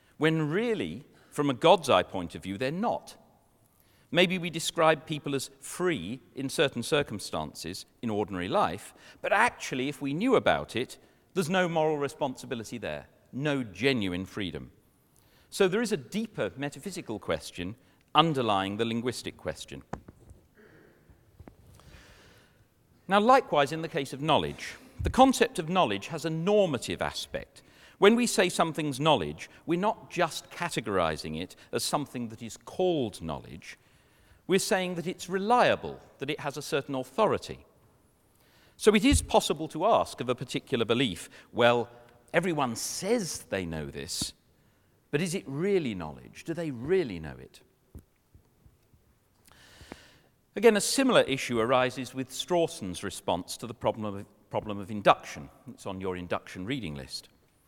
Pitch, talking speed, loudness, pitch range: 140 Hz, 145 wpm, -29 LUFS, 105-180 Hz